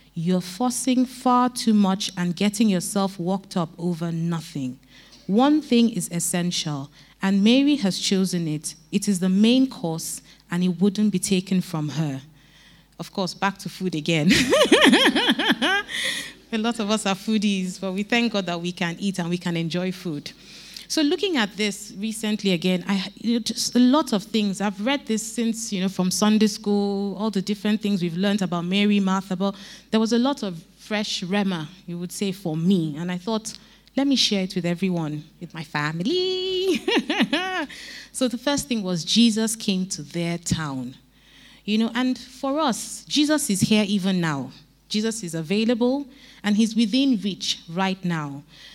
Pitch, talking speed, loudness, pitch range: 200 Hz, 175 wpm, -23 LUFS, 175-225 Hz